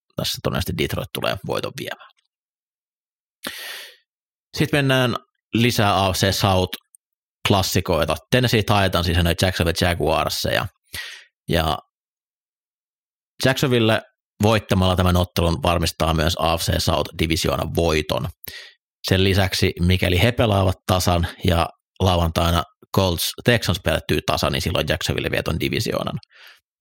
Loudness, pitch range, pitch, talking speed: -20 LUFS, 85-110 Hz, 95 Hz, 105 wpm